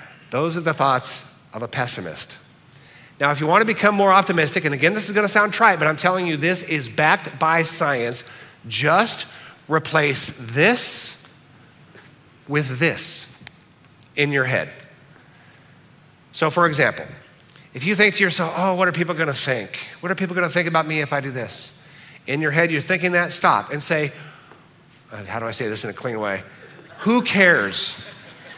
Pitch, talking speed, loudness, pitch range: 155 Hz, 185 wpm, -20 LUFS, 140-175 Hz